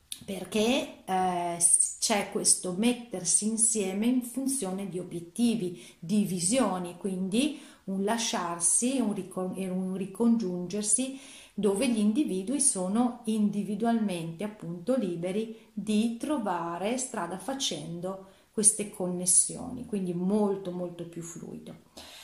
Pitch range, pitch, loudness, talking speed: 185-230 Hz, 205 Hz, -28 LUFS, 105 wpm